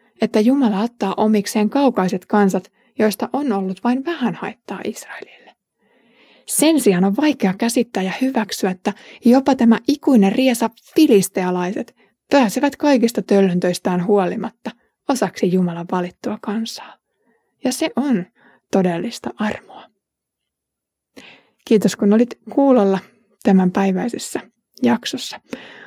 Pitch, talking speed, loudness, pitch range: 220 Hz, 105 wpm, -18 LUFS, 195-255 Hz